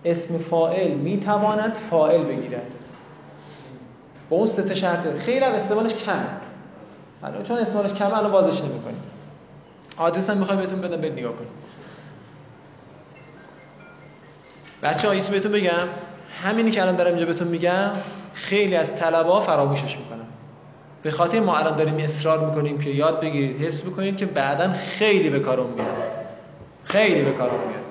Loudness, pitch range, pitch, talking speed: -22 LUFS, 155-200 Hz, 175 Hz, 145 wpm